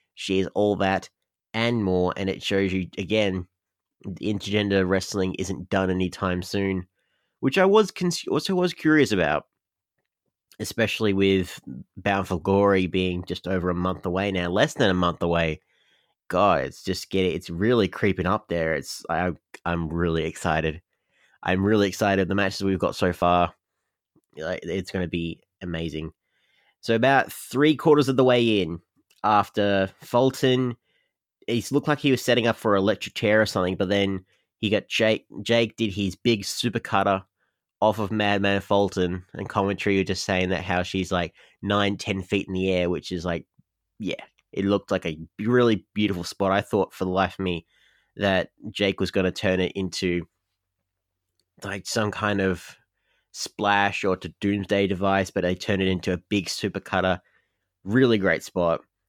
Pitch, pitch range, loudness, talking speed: 95 Hz, 90-105 Hz, -24 LUFS, 175 wpm